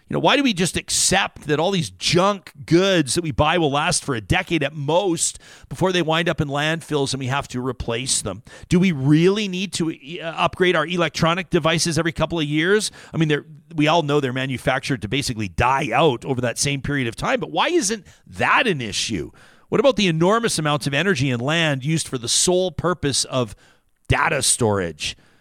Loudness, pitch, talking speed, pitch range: -20 LUFS, 155 Hz, 205 wpm, 140-175 Hz